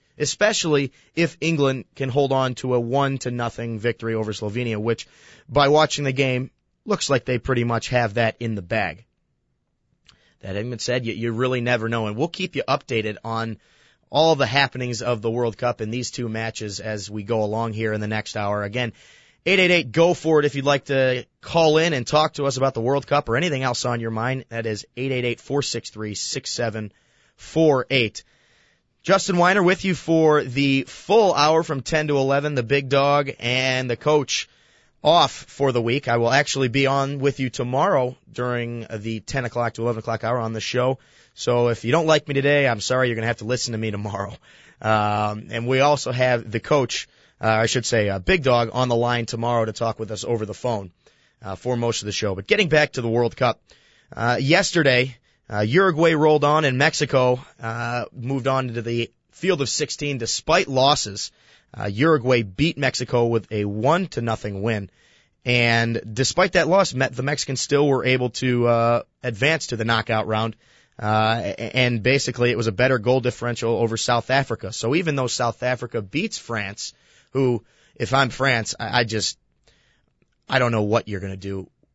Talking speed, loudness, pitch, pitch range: 200 wpm, -21 LUFS, 125 Hz, 115-140 Hz